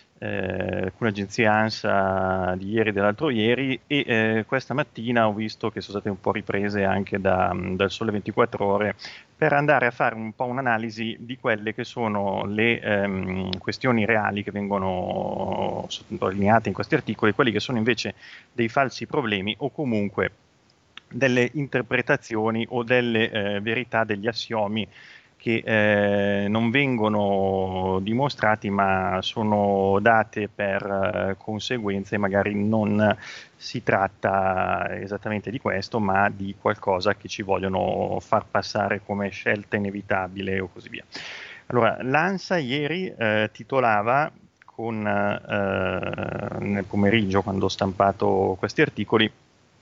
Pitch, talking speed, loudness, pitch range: 105 Hz, 130 wpm, -24 LUFS, 100-115 Hz